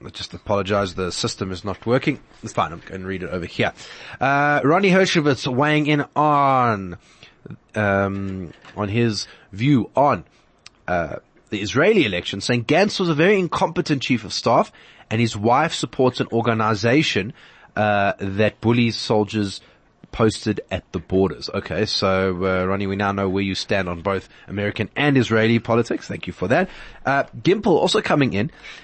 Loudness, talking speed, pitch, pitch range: -20 LUFS, 165 wpm, 110 Hz, 95-135 Hz